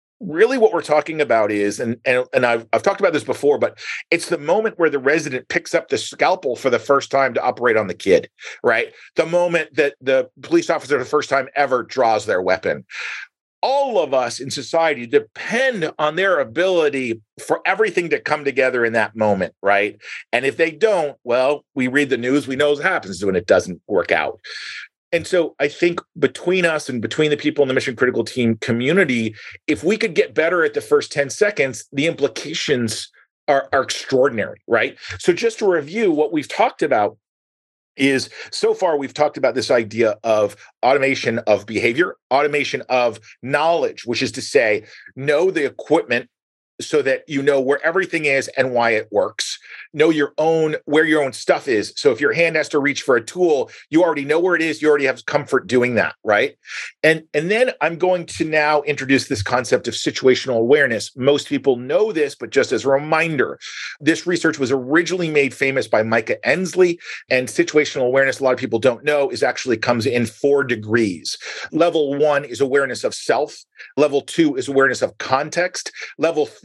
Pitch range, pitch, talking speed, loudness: 130-175 Hz, 145 Hz, 195 wpm, -19 LUFS